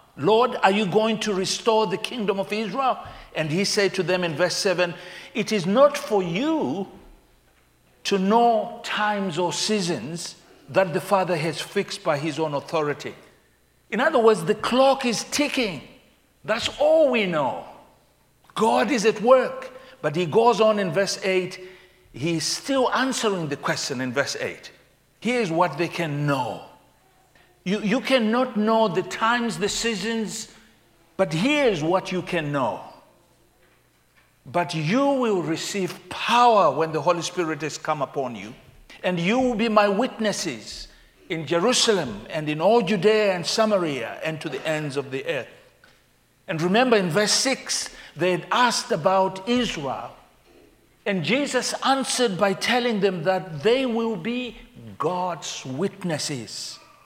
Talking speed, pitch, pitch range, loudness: 150 wpm, 195 Hz, 165-225 Hz, -23 LUFS